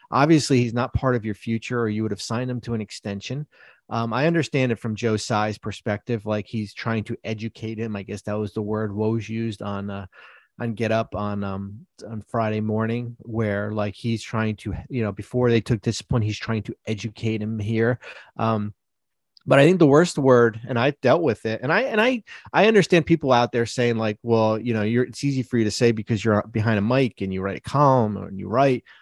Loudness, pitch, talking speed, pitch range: -23 LUFS, 115 Hz, 230 wpm, 105-125 Hz